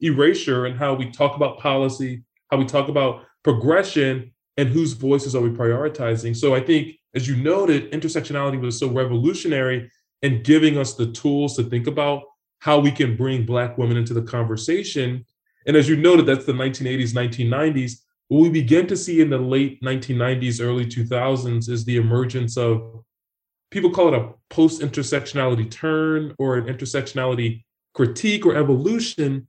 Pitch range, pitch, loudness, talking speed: 125-150 Hz, 135 Hz, -20 LUFS, 165 wpm